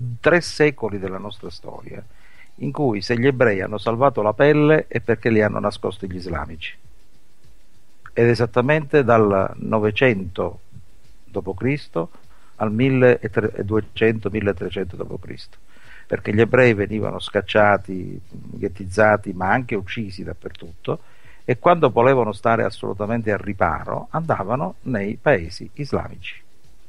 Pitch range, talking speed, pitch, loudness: 100-120 Hz, 110 wpm, 105 Hz, -20 LUFS